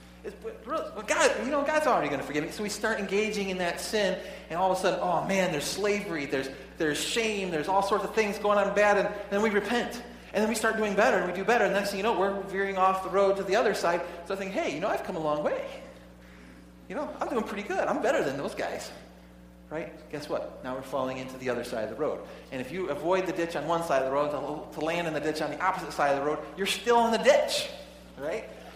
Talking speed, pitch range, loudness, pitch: 280 wpm, 145-205 Hz, -28 LUFS, 190 Hz